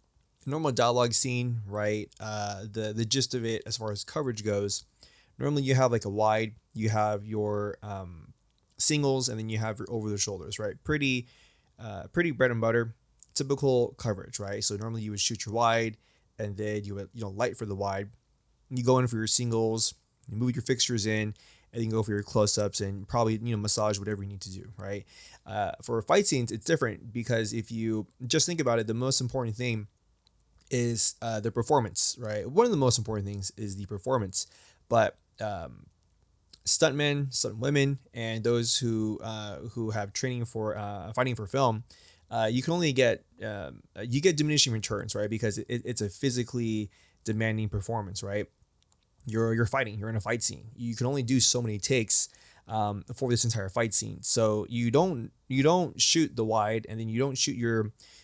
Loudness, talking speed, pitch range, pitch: -29 LUFS, 195 wpm, 105-125 Hz, 110 Hz